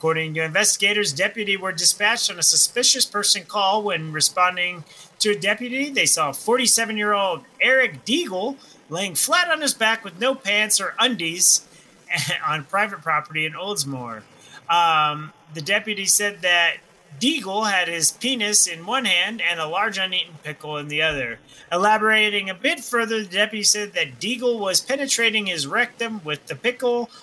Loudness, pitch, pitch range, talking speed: -19 LUFS, 205 Hz, 170-230 Hz, 160 wpm